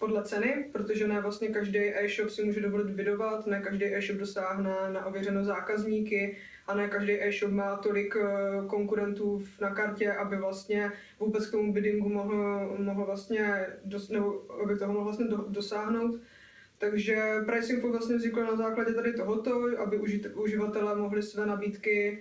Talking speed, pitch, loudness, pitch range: 150 wpm, 205 Hz, -31 LUFS, 200-215 Hz